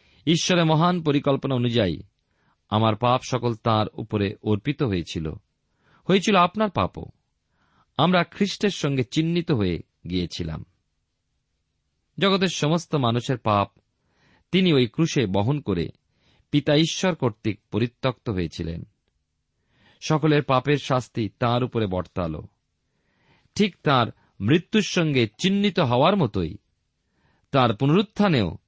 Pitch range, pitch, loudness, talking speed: 105-160 Hz, 125 Hz, -23 LUFS, 105 wpm